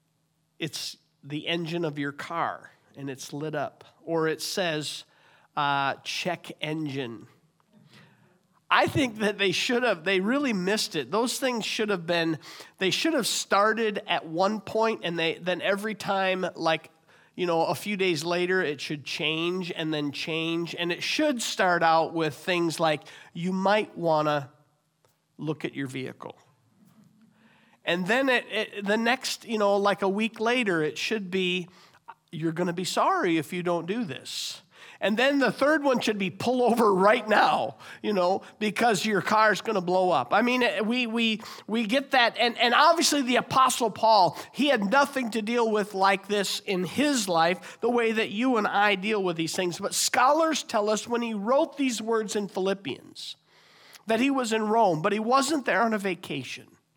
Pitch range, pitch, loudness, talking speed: 165-225 Hz, 195 Hz, -26 LUFS, 185 wpm